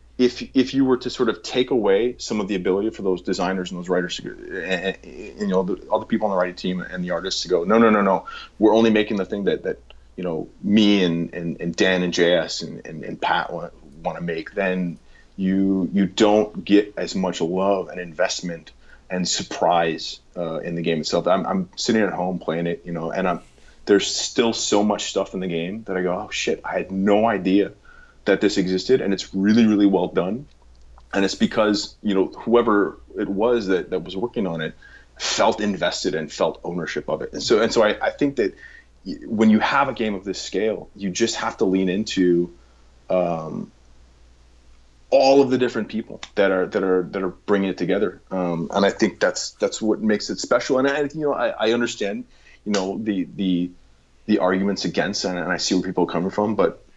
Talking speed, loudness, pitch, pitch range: 220 wpm, -22 LUFS, 95 Hz, 85-105 Hz